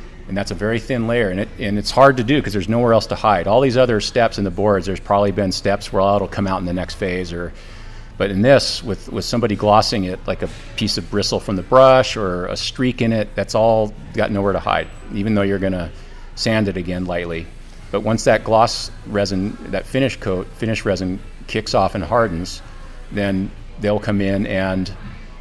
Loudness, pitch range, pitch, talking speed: -18 LUFS, 95-110 Hz, 100 Hz, 220 wpm